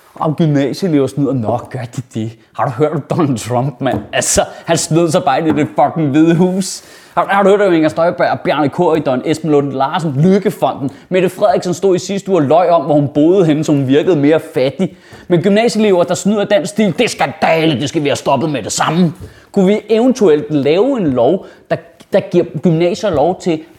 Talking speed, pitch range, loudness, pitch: 210 wpm, 145-185 Hz, -13 LUFS, 165 Hz